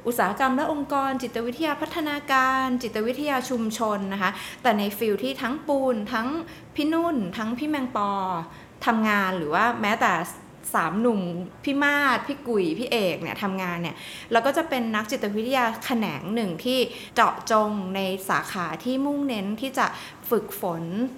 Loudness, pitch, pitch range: -25 LUFS, 235 Hz, 205-270 Hz